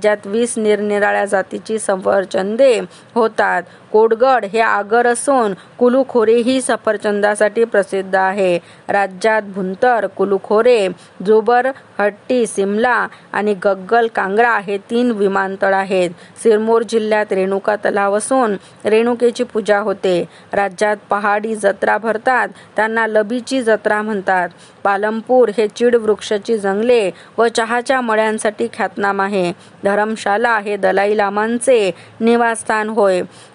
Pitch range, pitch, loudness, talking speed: 200-230 Hz, 215 Hz, -16 LUFS, 105 wpm